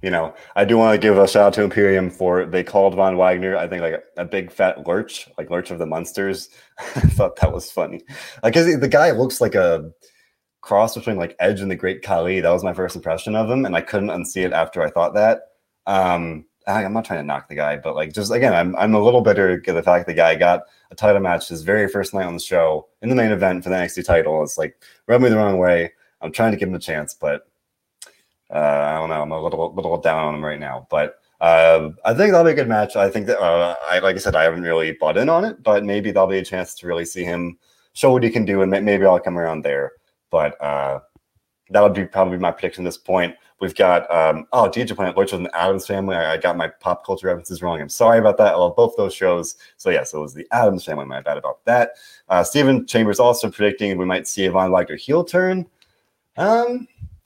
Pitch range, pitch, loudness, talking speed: 90-115 Hz, 95 Hz, -18 LUFS, 260 wpm